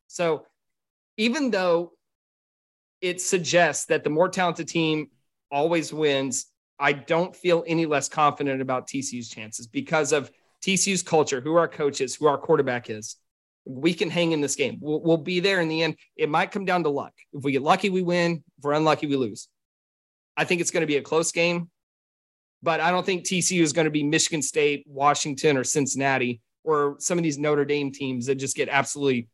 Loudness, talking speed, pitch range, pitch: -24 LUFS, 200 wpm, 135-170 Hz, 150 Hz